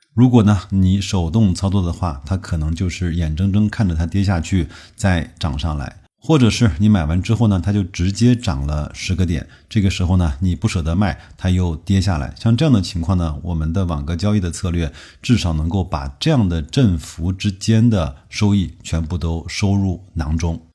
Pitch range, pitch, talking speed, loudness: 85-105 Hz, 95 Hz, 290 characters per minute, -18 LUFS